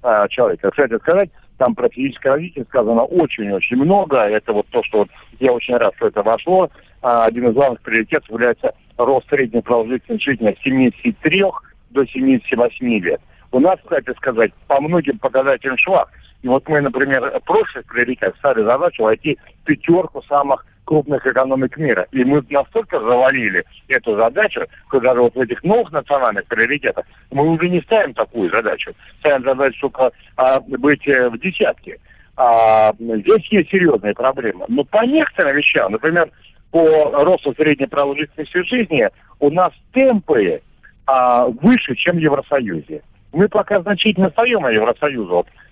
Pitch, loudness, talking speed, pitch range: 145 Hz, -16 LUFS, 150 wpm, 130-210 Hz